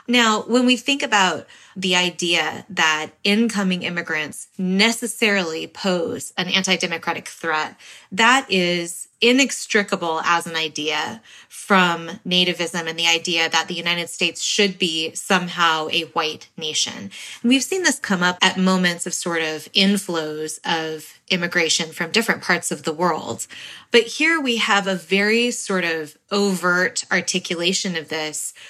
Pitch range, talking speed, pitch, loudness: 165-200 Hz, 140 wpm, 180 Hz, -19 LUFS